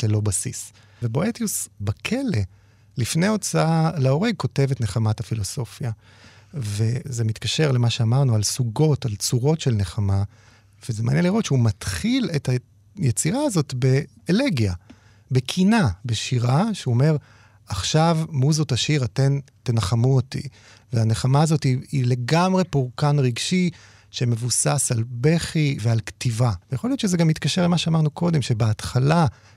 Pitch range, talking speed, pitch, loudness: 110-155 Hz, 125 wpm, 125 Hz, -22 LUFS